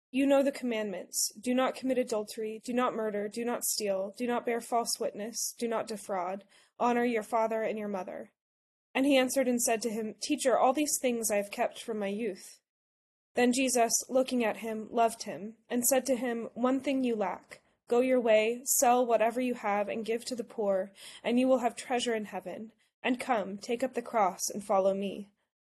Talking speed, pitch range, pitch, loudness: 205 wpm, 210-250 Hz, 230 Hz, -30 LUFS